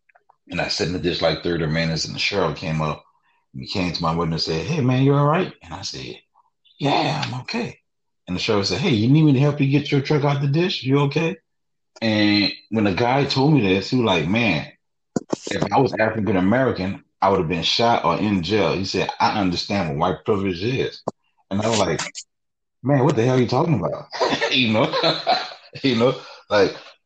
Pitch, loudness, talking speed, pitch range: 115 Hz, -20 LUFS, 225 wpm, 90-140 Hz